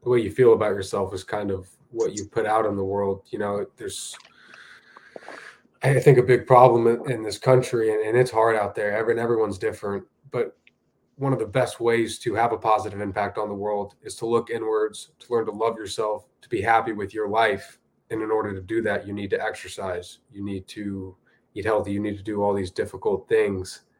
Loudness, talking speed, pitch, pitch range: -24 LUFS, 220 wpm, 110 Hz, 100-120 Hz